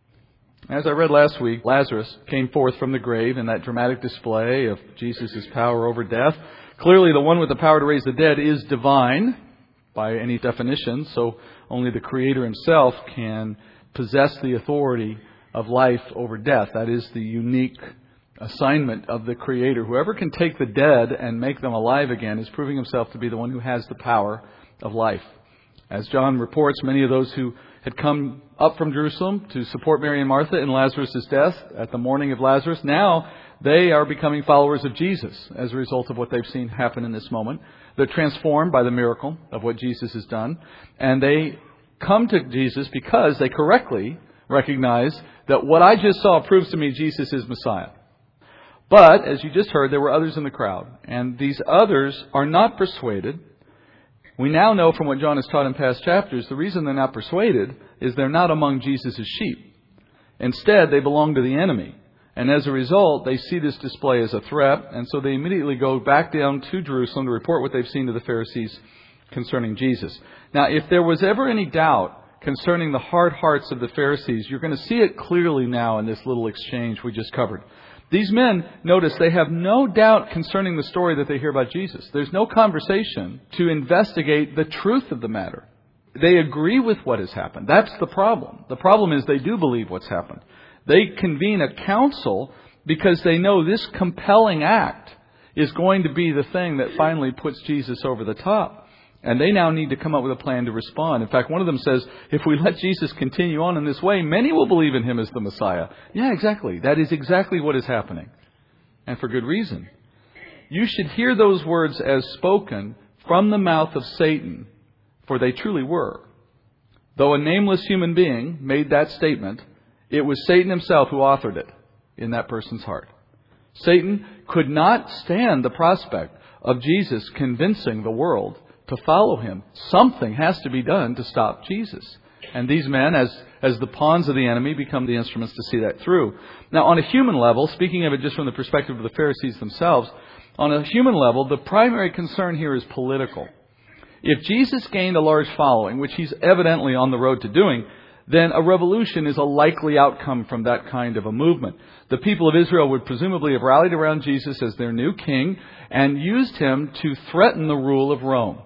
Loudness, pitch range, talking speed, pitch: -20 LUFS, 125-165 Hz, 195 wpm, 140 Hz